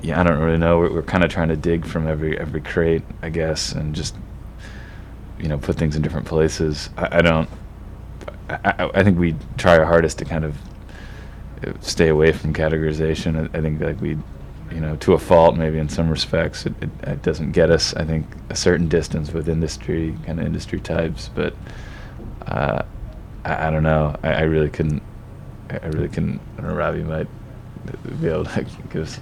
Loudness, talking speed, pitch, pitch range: -20 LUFS, 205 wpm, 80 Hz, 80-90 Hz